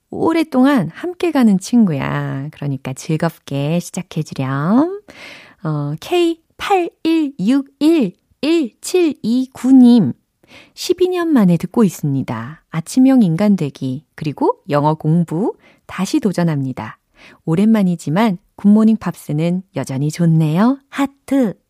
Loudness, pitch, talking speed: -16 LUFS, 195 Hz, 210 characters per minute